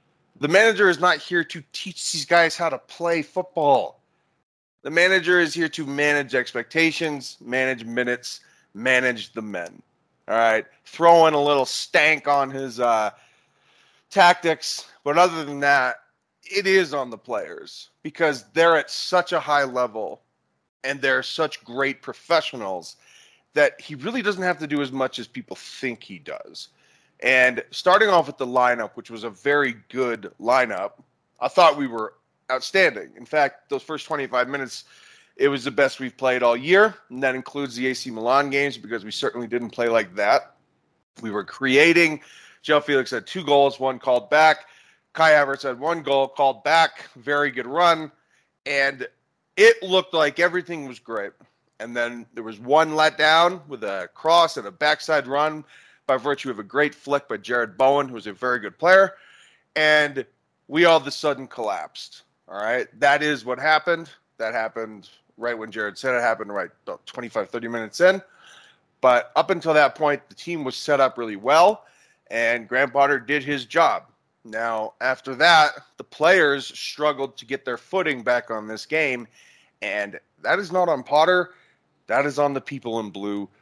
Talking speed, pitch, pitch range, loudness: 175 wpm, 145 Hz, 125-160 Hz, -21 LUFS